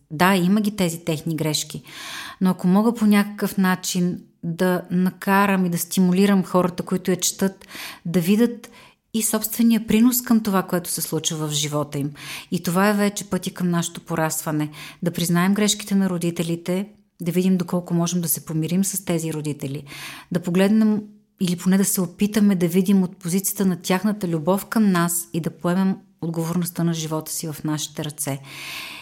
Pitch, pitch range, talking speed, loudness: 180 Hz, 170-200 Hz, 170 wpm, -22 LUFS